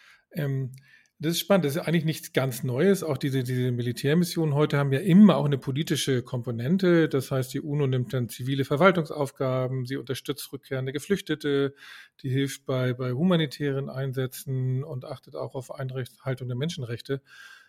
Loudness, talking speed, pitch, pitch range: -26 LUFS, 155 wpm, 140 Hz, 130-155 Hz